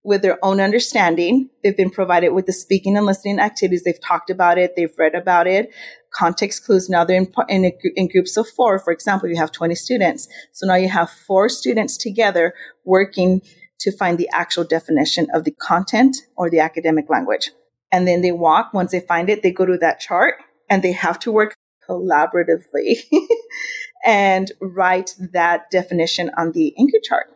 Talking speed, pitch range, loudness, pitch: 185 wpm, 175-205 Hz, -17 LUFS, 185 Hz